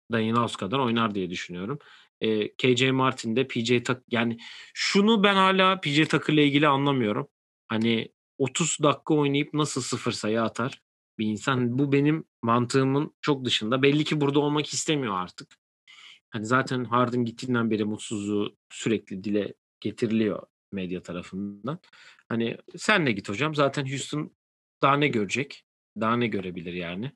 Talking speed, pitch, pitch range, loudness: 150 wpm, 125 Hz, 110-145 Hz, -25 LUFS